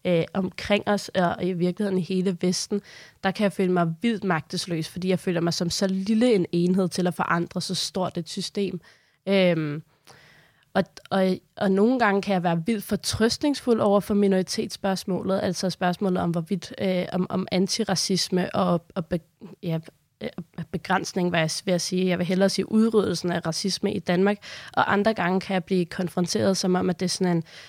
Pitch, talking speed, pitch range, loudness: 185 Hz, 190 wpm, 175-195 Hz, -25 LUFS